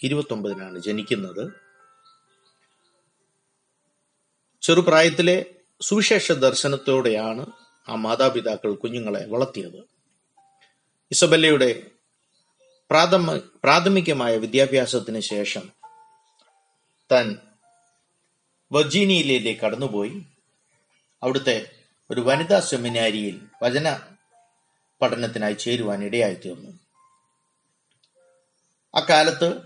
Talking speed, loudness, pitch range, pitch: 55 wpm, -21 LUFS, 125-195 Hz, 165 Hz